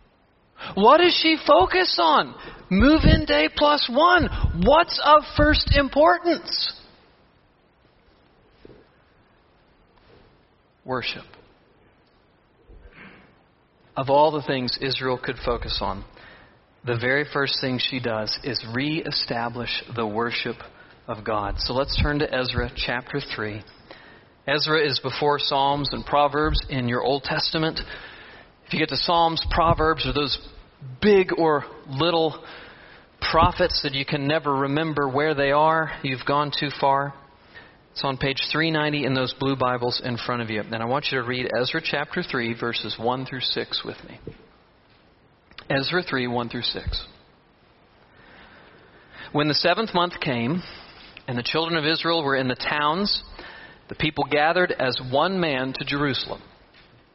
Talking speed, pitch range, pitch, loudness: 135 wpm, 125-160 Hz, 140 Hz, -22 LUFS